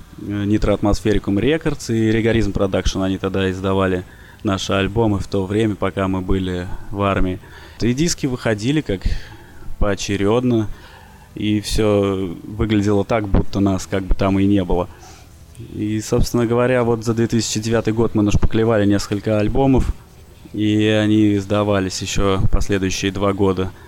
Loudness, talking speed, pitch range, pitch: -19 LUFS, 135 wpm, 95-110 Hz, 100 Hz